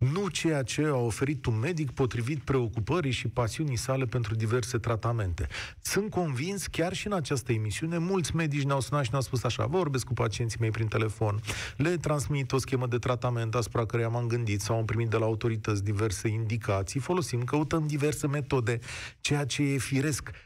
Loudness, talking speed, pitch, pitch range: -30 LUFS, 180 wpm, 125 Hz, 115-145 Hz